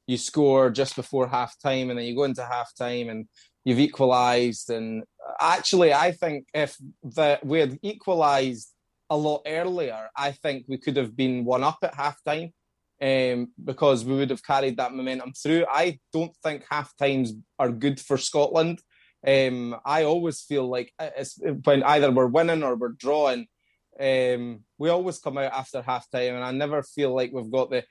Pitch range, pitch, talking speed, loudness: 125-150 Hz, 135 Hz, 185 wpm, -25 LUFS